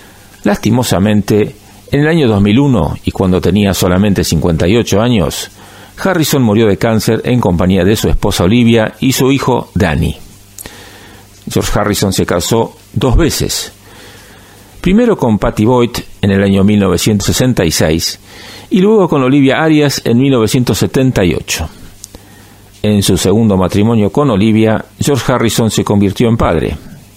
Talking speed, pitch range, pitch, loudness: 130 wpm, 100-120 Hz, 105 Hz, -11 LUFS